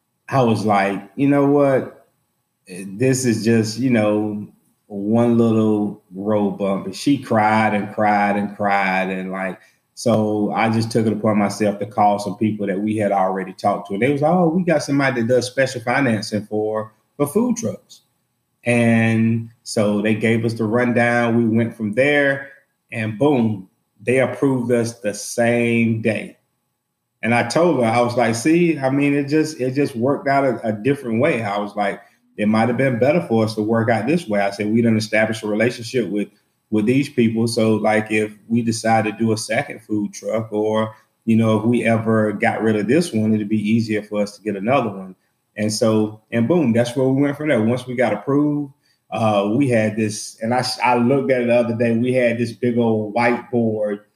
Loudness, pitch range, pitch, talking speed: -19 LUFS, 105-125 Hz, 115 Hz, 205 wpm